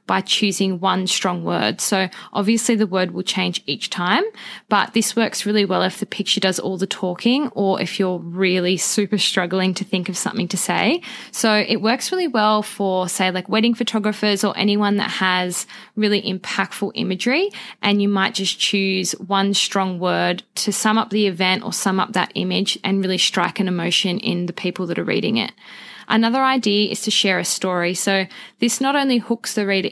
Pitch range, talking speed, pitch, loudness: 185-215 Hz, 195 wpm, 200 Hz, -19 LUFS